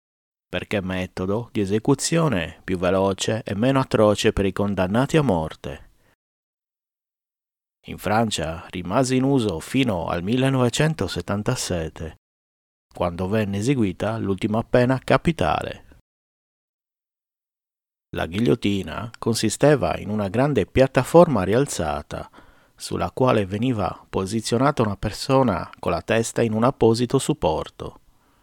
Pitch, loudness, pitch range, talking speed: 110 Hz, -22 LUFS, 95-130 Hz, 105 wpm